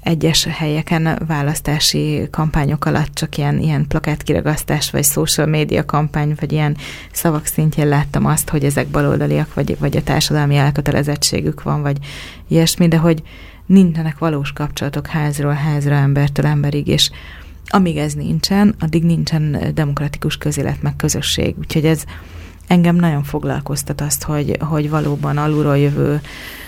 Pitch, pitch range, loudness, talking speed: 150 Hz, 145-160 Hz, -16 LUFS, 135 wpm